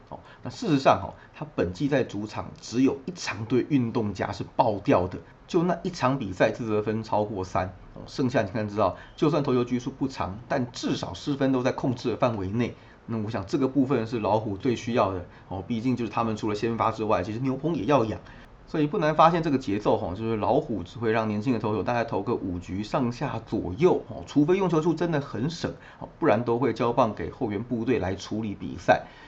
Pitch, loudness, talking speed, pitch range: 115 Hz, -27 LUFS, 325 characters per minute, 105-135 Hz